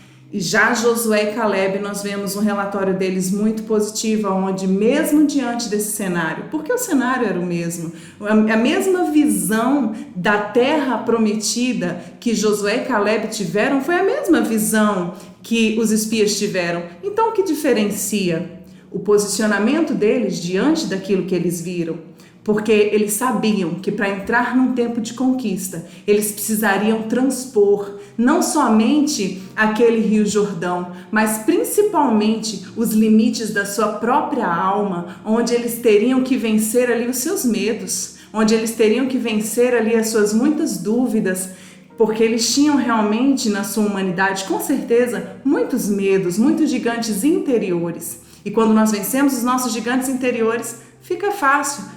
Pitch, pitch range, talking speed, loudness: 220 Hz, 200-245 Hz, 140 wpm, -18 LUFS